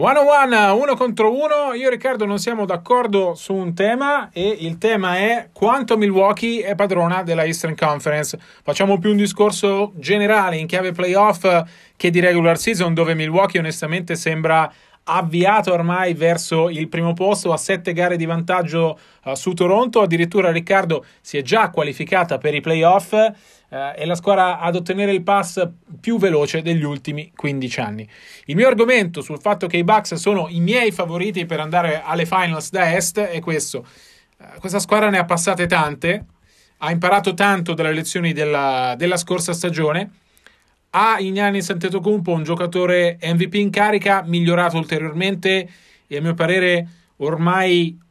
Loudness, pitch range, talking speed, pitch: -18 LUFS, 165-200 Hz, 160 wpm, 180 Hz